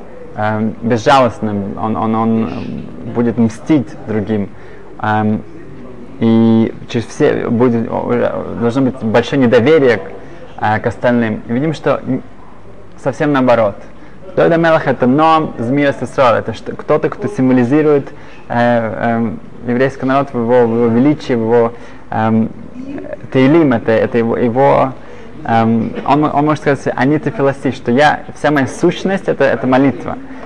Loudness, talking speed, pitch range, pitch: -14 LUFS, 110 wpm, 115-140 Hz, 125 Hz